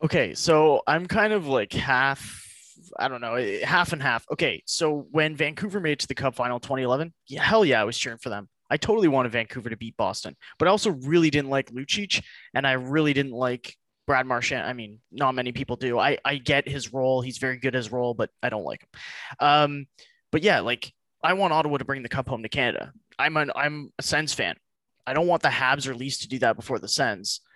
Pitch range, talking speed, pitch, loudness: 125-155 Hz, 235 wpm, 135 Hz, -25 LUFS